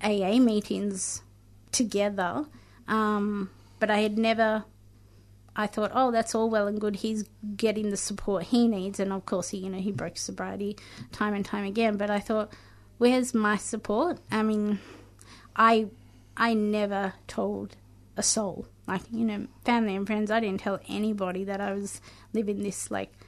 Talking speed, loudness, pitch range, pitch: 170 wpm, -28 LUFS, 190-220 Hz, 205 Hz